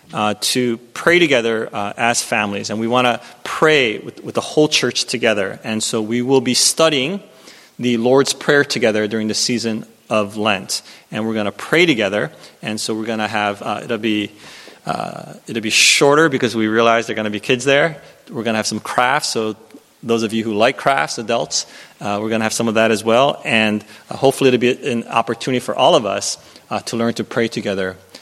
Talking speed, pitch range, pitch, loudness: 220 wpm, 110-125 Hz, 115 Hz, -17 LUFS